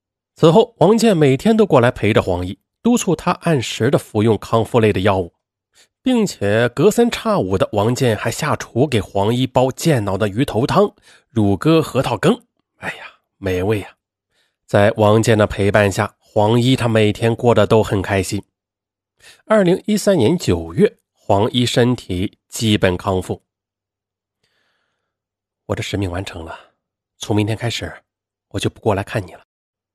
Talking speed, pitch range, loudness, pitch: 225 characters per minute, 100-135 Hz, -17 LUFS, 110 Hz